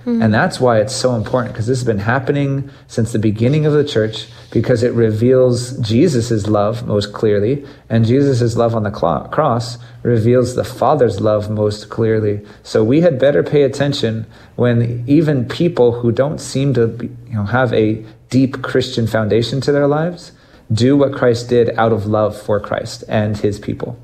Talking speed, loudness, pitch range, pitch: 180 wpm, -16 LUFS, 110-130 Hz, 120 Hz